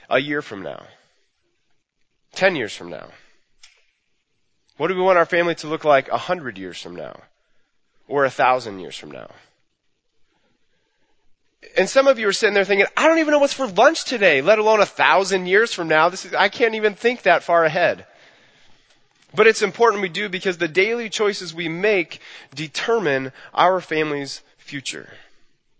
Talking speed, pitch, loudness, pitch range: 175 wpm, 190 Hz, -19 LUFS, 160-220 Hz